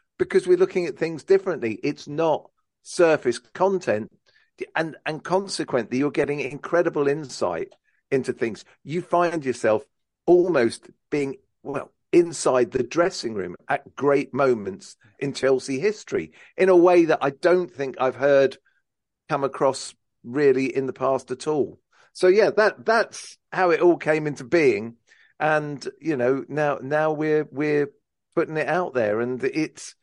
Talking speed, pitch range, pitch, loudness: 150 wpm, 140-190 Hz, 155 Hz, -23 LUFS